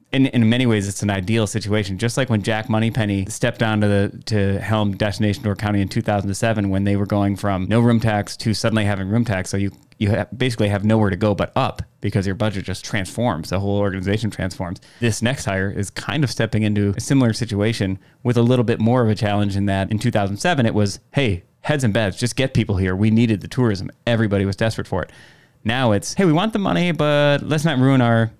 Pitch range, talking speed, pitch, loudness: 100-120 Hz, 245 wpm, 110 Hz, -20 LUFS